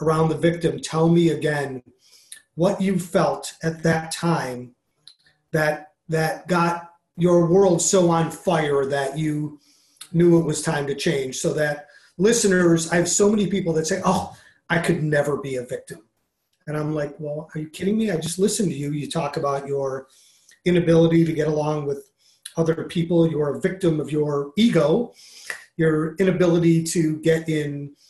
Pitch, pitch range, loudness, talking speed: 160 Hz, 150-175 Hz, -21 LUFS, 170 wpm